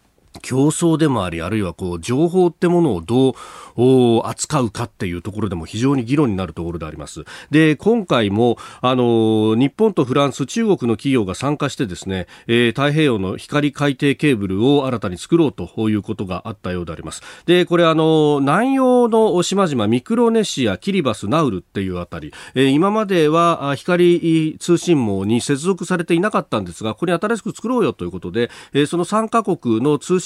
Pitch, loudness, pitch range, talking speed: 140 Hz, -18 LUFS, 110-170 Hz, 385 characters per minute